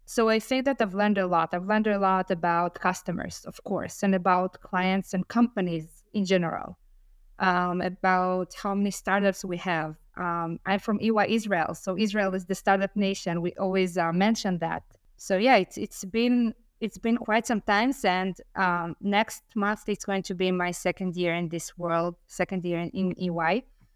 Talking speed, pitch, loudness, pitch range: 190 wpm, 190 Hz, -27 LUFS, 175-205 Hz